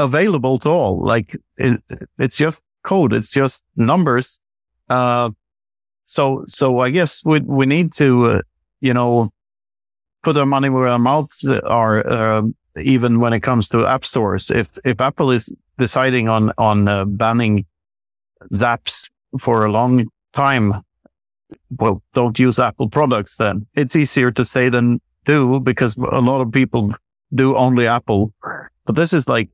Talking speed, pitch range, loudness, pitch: 155 wpm, 110-135 Hz, -17 LUFS, 125 Hz